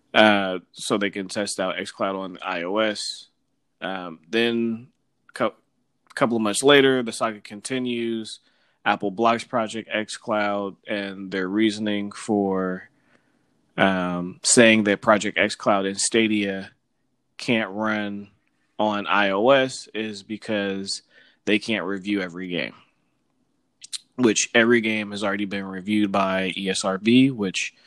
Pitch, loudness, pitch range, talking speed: 105 Hz, -23 LUFS, 100-115 Hz, 120 wpm